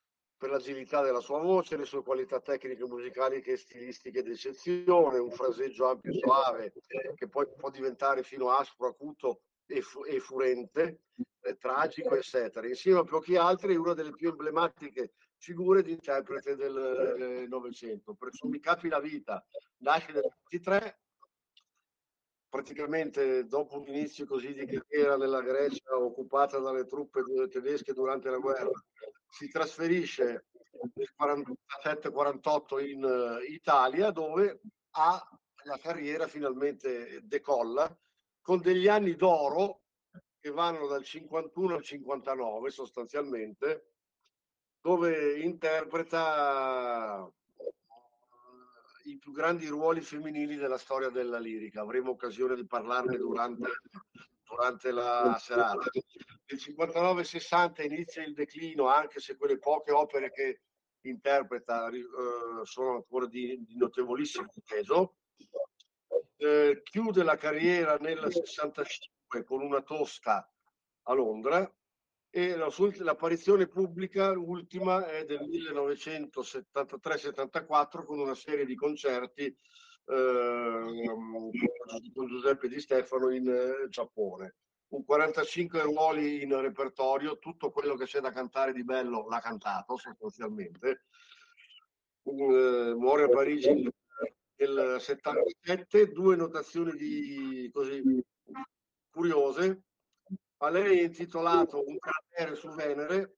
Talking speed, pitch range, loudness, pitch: 115 wpm, 135-205 Hz, -31 LUFS, 155 Hz